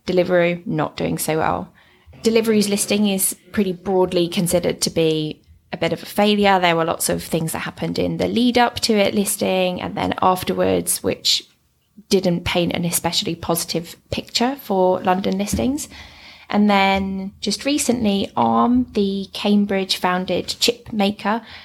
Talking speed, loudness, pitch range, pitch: 150 wpm, -19 LUFS, 175-210 Hz, 195 Hz